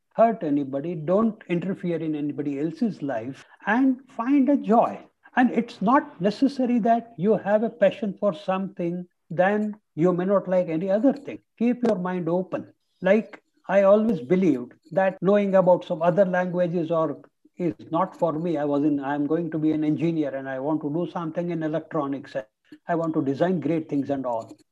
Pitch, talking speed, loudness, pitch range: 180 Hz, 185 wpm, -24 LUFS, 155-215 Hz